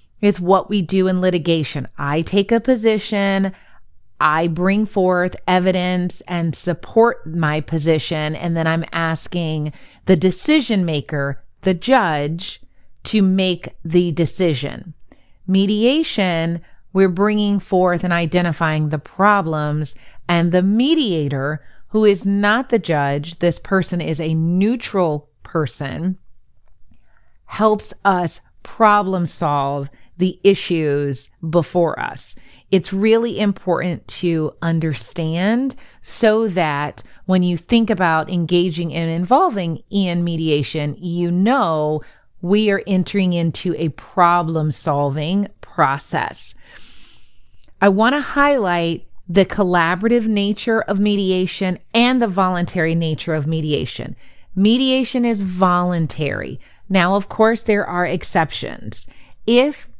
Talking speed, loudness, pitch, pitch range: 110 wpm, -18 LUFS, 180 Hz, 160-200 Hz